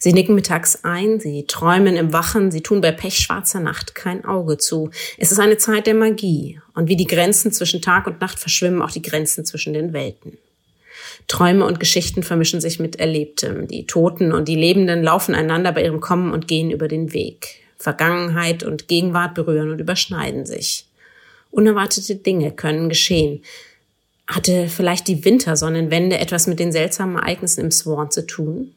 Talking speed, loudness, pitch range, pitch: 175 wpm, -18 LUFS, 160-185 Hz, 175 Hz